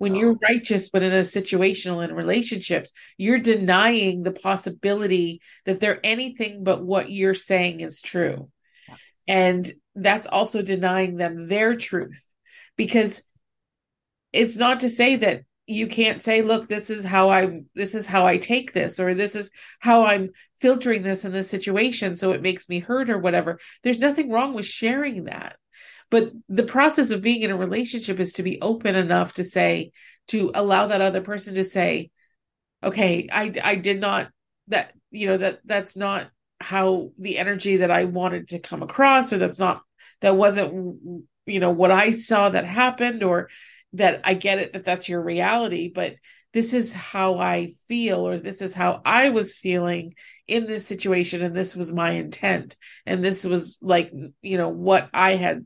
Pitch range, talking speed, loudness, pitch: 185-220 Hz, 180 wpm, -22 LUFS, 195 Hz